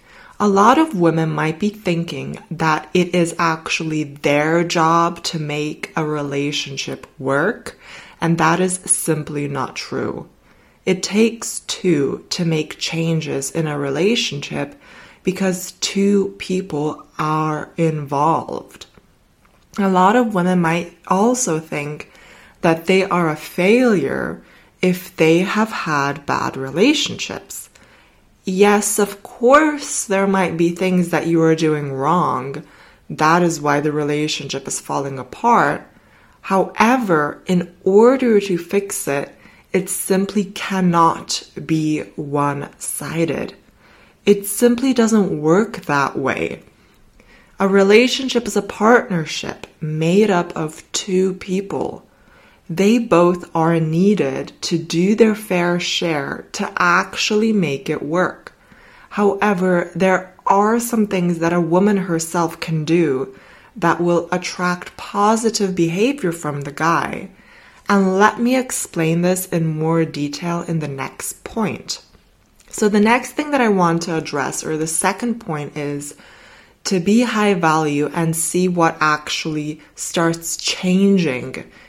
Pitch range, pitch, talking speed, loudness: 160-200 Hz, 175 Hz, 125 wpm, -18 LUFS